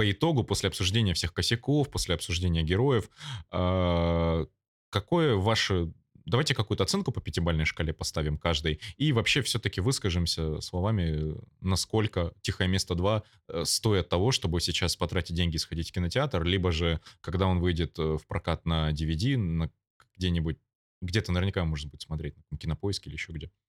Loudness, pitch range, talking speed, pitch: -29 LUFS, 85-105 Hz, 150 wpm, 90 Hz